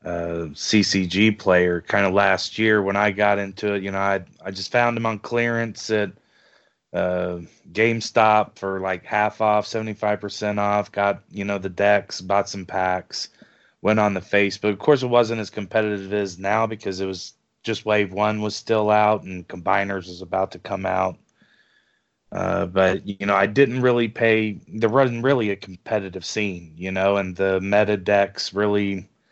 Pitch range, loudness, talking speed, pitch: 95-110 Hz, -22 LUFS, 180 wpm, 100 Hz